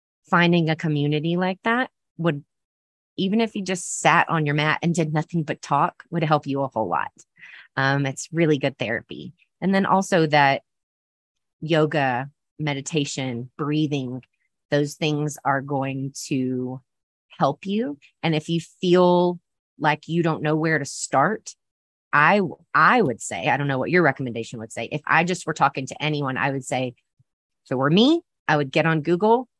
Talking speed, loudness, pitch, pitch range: 175 wpm, -22 LUFS, 150 Hz, 135-170 Hz